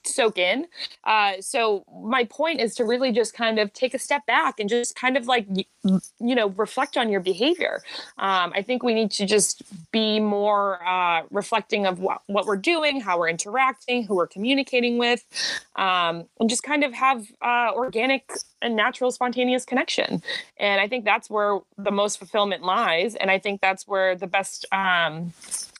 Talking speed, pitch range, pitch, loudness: 185 wpm, 195-250 Hz, 220 Hz, -23 LUFS